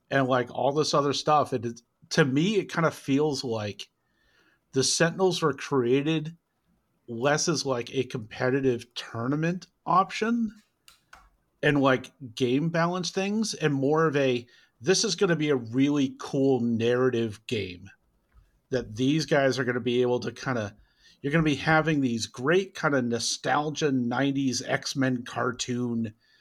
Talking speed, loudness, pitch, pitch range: 155 wpm, -26 LUFS, 135 Hz, 125-155 Hz